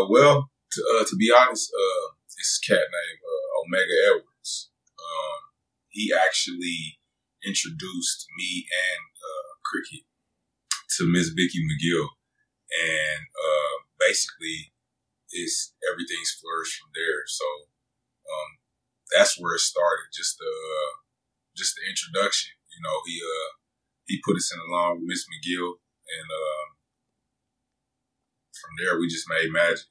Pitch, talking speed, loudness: 145 Hz, 130 wpm, -25 LUFS